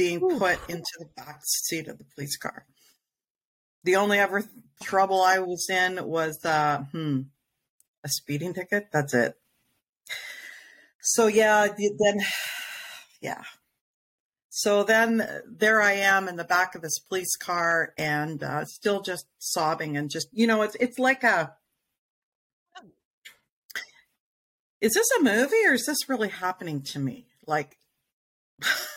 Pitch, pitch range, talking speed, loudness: 185 Hz, 155-215 Hz, 140 wpm, -25 LUFS